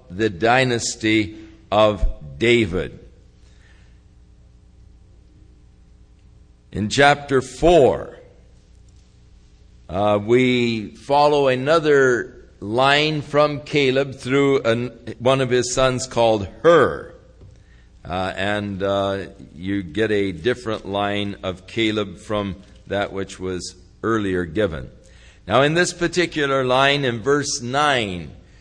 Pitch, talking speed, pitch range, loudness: 110 Hz, 95 wpm, 95-135 Hz, -19 LUFS